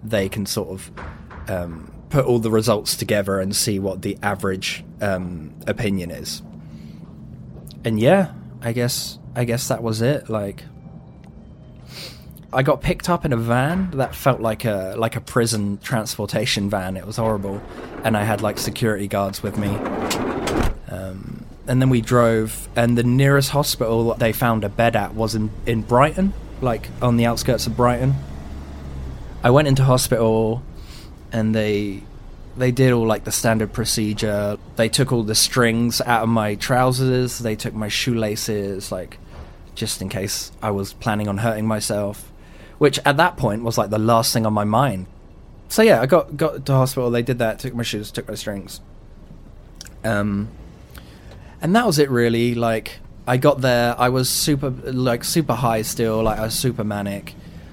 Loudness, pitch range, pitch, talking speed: -20 LUFS, 100-125 Hz, 110 Hz, 175 wpm